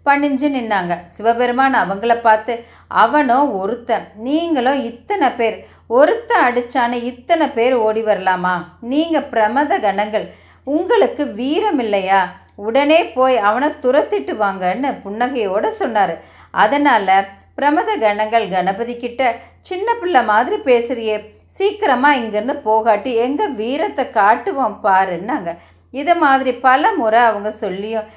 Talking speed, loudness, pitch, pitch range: 110 wpm, -16 LUFS, 245 Hz, 215-290 Hz